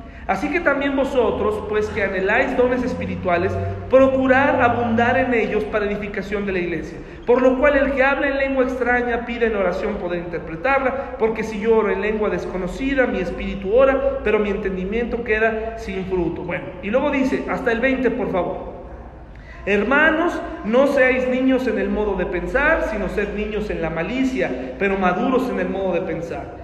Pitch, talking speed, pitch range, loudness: 220 Hz, 180 wpm, 190-260 Hz, -20 LUFS